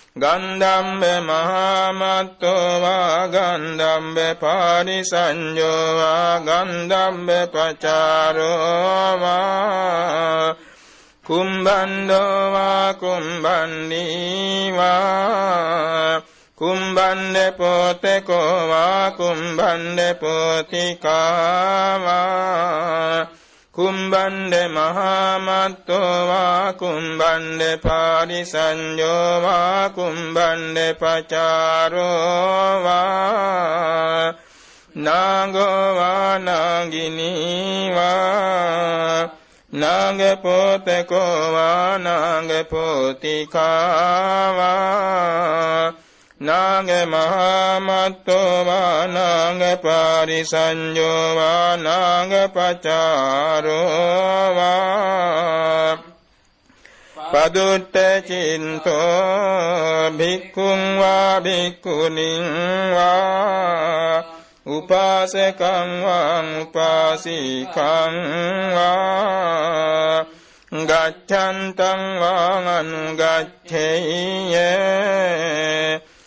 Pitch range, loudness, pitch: 160-190 Hz, -18 LUFS, 175 Hz